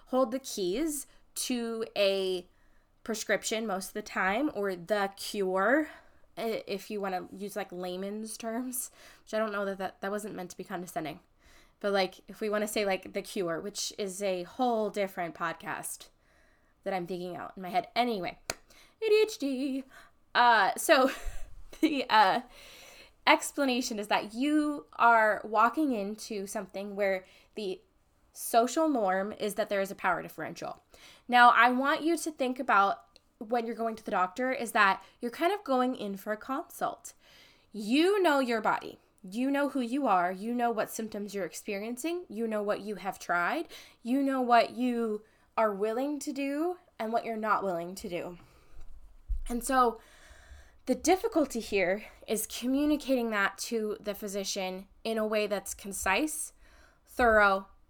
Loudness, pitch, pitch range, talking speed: -30 LUFS, 220 Hz, 195-260 Hz, 165 wpm